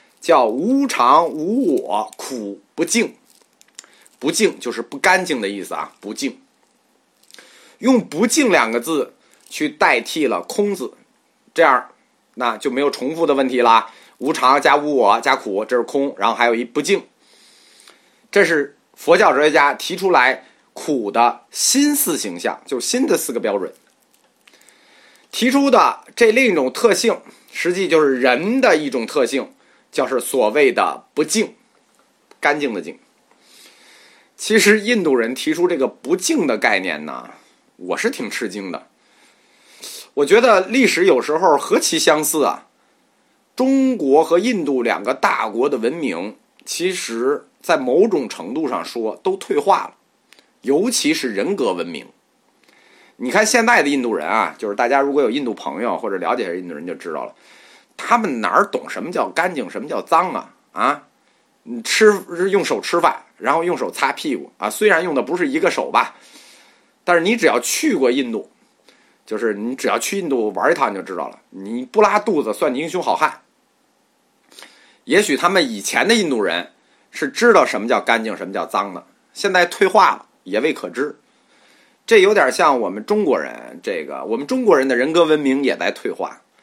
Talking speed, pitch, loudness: 240 characters per minute, 235 Hz, -17 LUFS